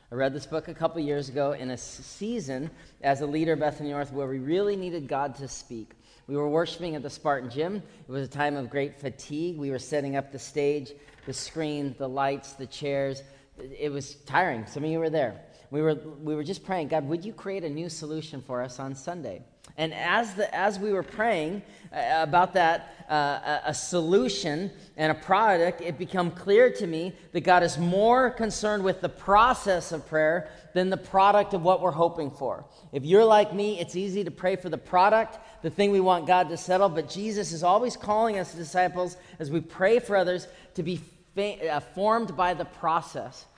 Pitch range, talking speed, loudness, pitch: 145-185 Hz, 210 wpm, -27 LUFS, 165 Hz